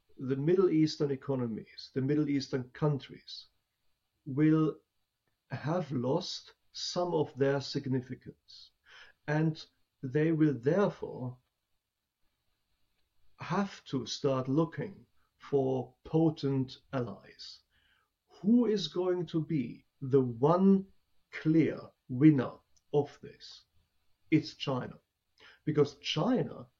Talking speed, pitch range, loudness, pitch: 90 wpm, 130-155 Hz, -31 LUFS, 140 Hz